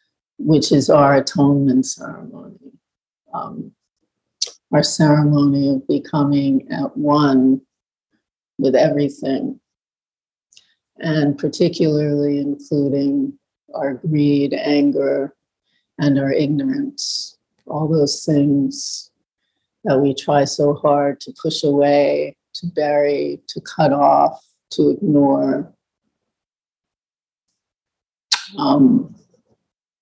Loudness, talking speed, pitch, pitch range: -17 LUFS, 85 wpm, 145 Hz, 140-150 Hz